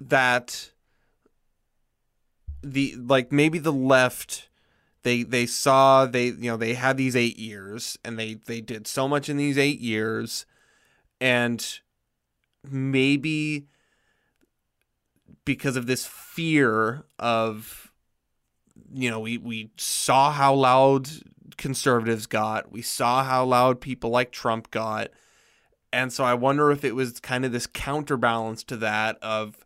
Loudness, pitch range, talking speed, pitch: -24 LUFS, 115-135 Hz, 130 wpm, 125 Hz